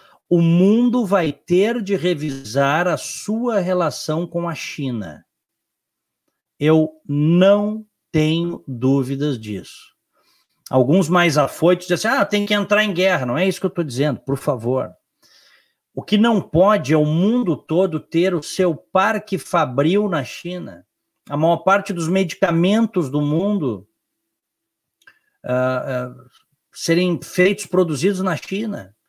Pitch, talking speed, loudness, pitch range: 175 Hz, 135 wpm, -19 LUFS, 150-195 Hz